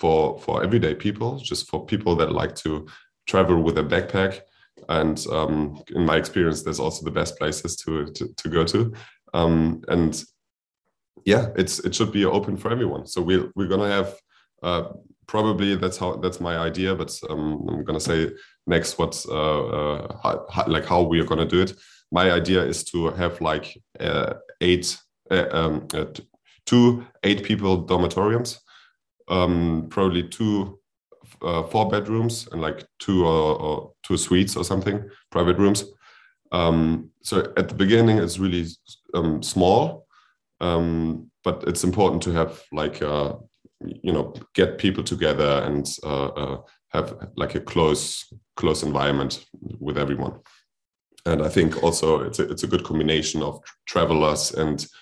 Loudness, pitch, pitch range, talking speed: -23 LUFS, 85 Hz, 80-95 Hz, 165 wpm